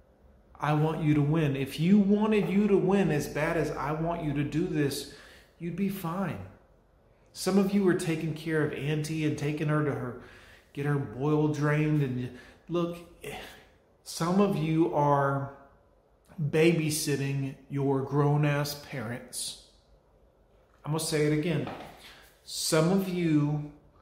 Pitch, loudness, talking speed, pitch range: 150 Hz, -28 LUFS, 150 wpm, 140-165 Hz